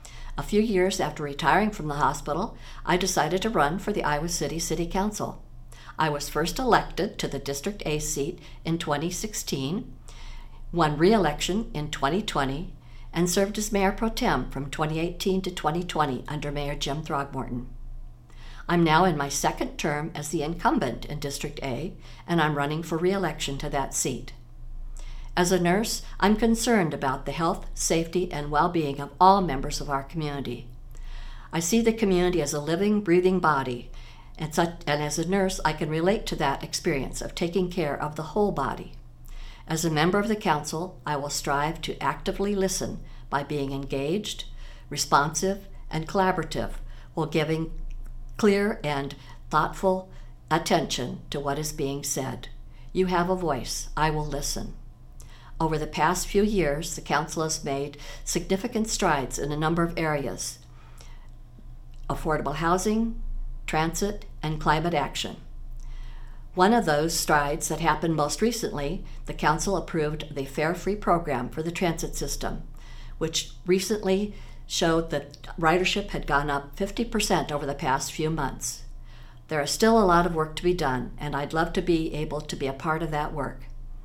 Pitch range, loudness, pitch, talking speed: 140-180 Hz, -26 LUFS, 155 Hz, 160 wpm